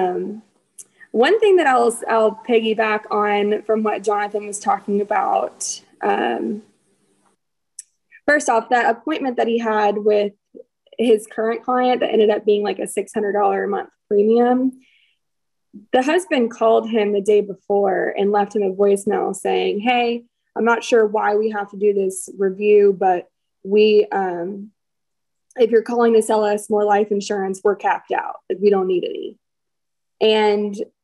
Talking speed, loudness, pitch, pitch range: 155 wpm, -18 LUFS, 215 Hz, 205-235 Hz